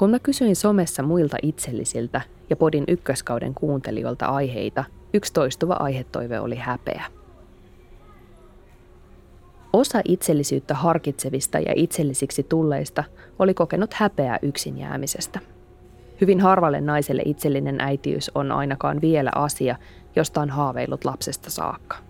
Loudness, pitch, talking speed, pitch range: -23 LUFS, 145 Hz, 110 wpm, 120-165 Hz